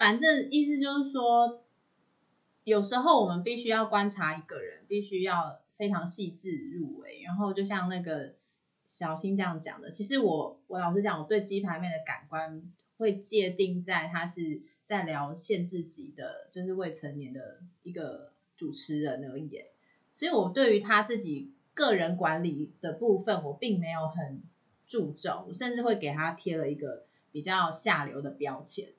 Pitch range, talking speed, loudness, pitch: 160-215 Hz, 250 characters per minute, -31 LUFS, 185 Hz